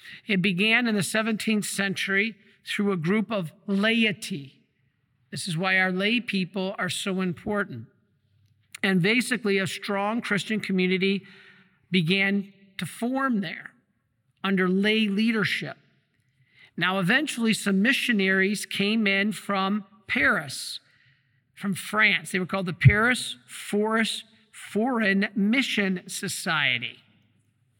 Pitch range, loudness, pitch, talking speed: 175-210 Hz, -25 LUFS, 195 Hz, 110 wpm